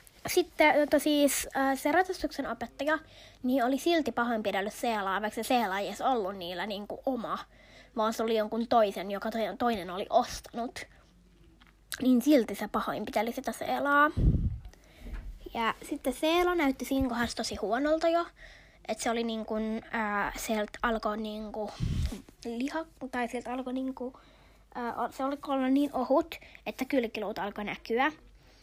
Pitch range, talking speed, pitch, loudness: 220-275 Hz, 130 wpm, 240 Hz, -30 LUFS